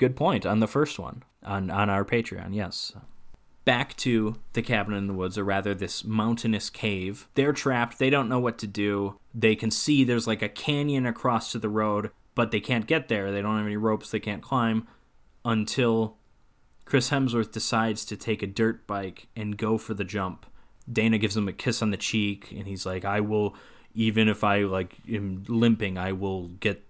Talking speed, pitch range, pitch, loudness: 205 wpm, 100-115 Hz, 110 Hz, -27 LUFS